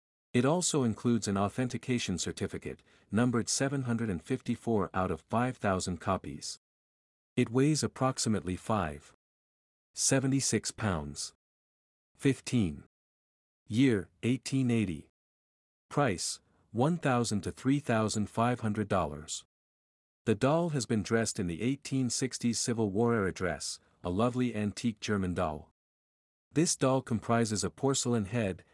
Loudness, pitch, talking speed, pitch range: -31 LUFS, 110 Hz, 100 wpm, 90-125 Hz